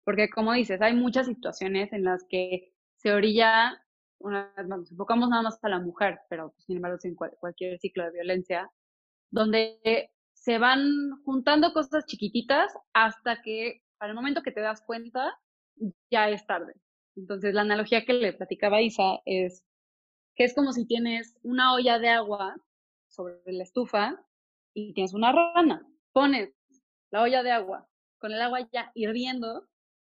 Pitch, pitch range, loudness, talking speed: 225 Hz, 195-245 Hz, -27 LUFS, 165 wpm